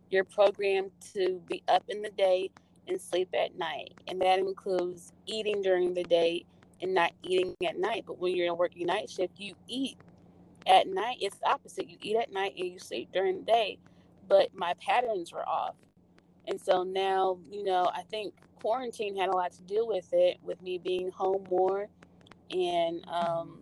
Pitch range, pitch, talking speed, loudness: 180-235 Hz, 190 Hz, 195 wpm, -30 LUFS